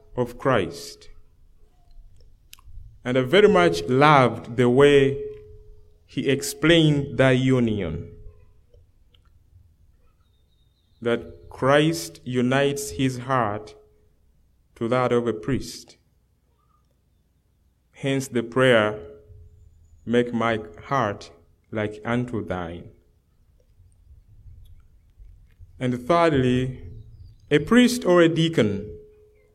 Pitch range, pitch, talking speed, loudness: 85-125 Hz, 105 Hz, 80 wpm, -21 LUFS